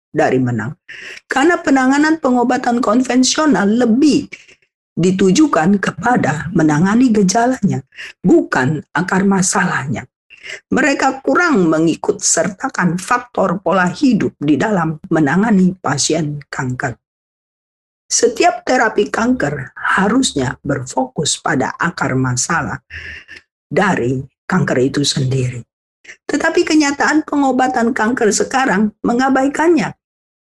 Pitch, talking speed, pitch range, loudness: 205 Hz, 85 wpm, 155-260 Hz, -15 LUFS